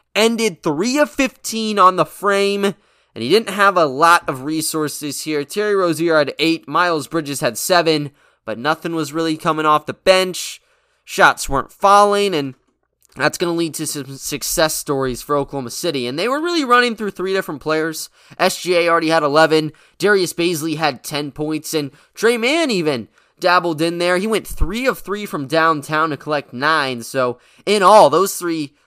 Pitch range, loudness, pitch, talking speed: 150-195 Hz, -17 LUFS, 165 Hz, 180 wpm